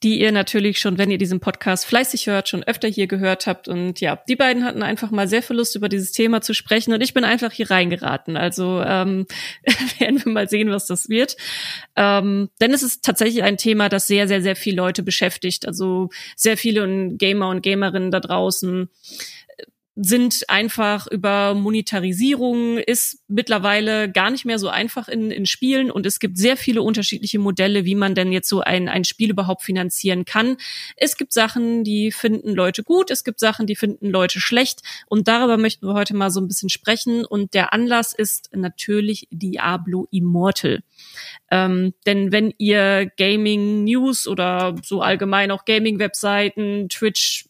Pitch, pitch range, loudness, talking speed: 205 Hz, 190-225 Hz, -19 LUFS, 180 wpm